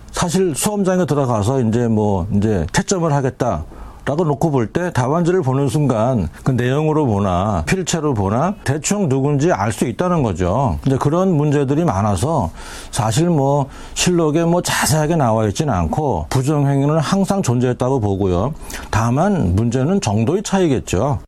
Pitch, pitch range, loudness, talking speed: 140 Hz, 115-170 Hz, -17 LUFS, 325 characters per minute